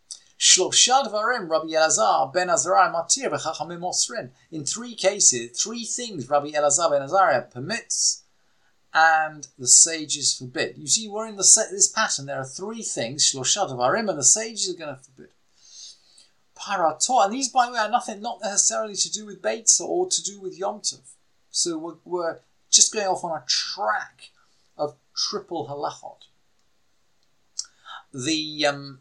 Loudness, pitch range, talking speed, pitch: -21 LUFS, 150-220 Hz, 135 wpm, 185 Hz